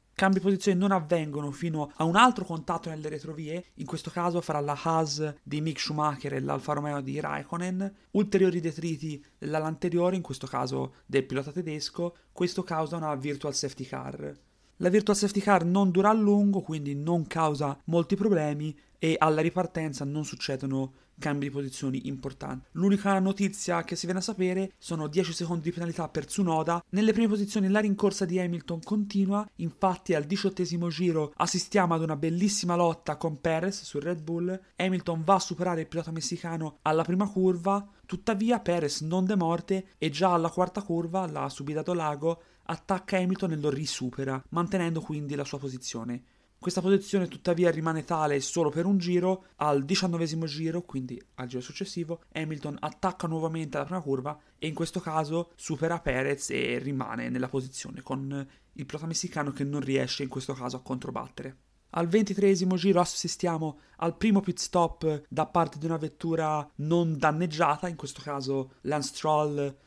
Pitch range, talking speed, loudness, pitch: 150-185 Hz, 170 wpm, -29 LUFS, 165 Hz